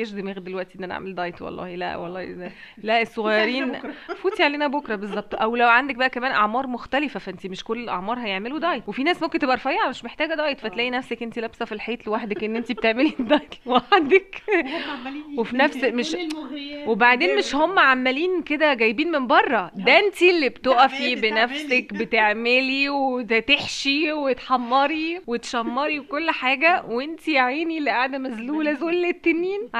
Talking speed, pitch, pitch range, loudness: 160 wpm, 260 Hz, 230-300 Hz, -21 LUFS